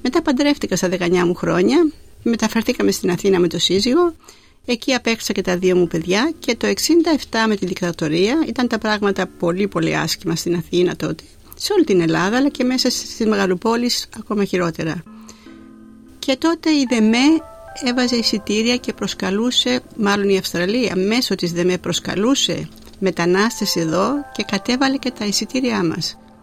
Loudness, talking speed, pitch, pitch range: -18 LUFS, 155 wpm, 215 Hz, 180-250 Hz